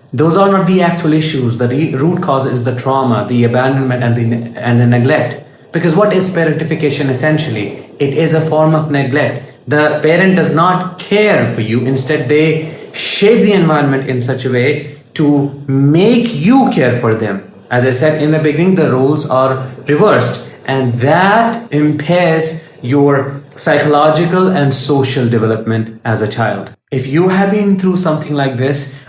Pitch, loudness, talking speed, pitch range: 145 Hz, -12 LUFS, 170 wpm, 130-160 Hz